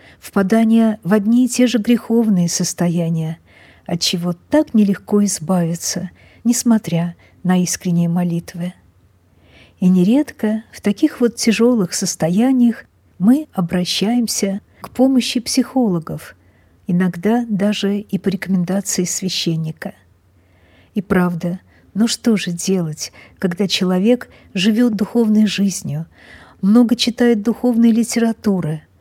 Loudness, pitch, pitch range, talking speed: -17 LUFS, 200 Hz, 175-230 Hz, 105 wpm